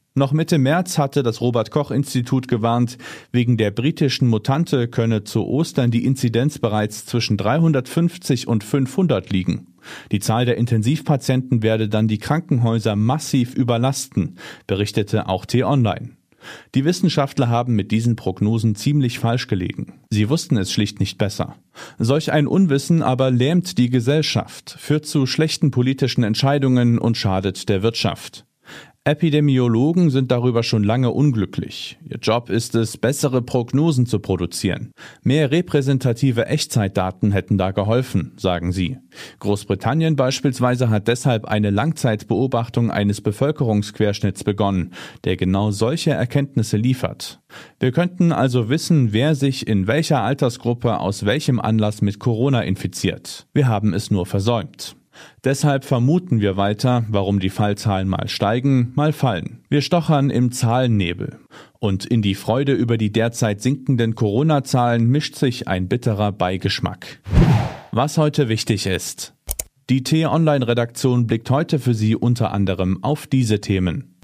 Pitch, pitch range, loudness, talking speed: 120 Hz, 105-140 Hz, -19 LUFS, 140 wpm